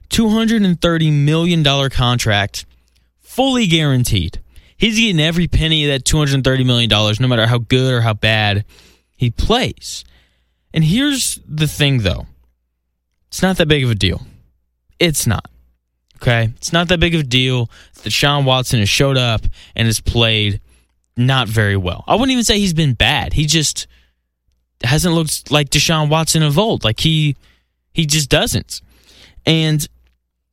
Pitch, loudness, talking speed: 125 Hz, -15 LUFS, 170 wpm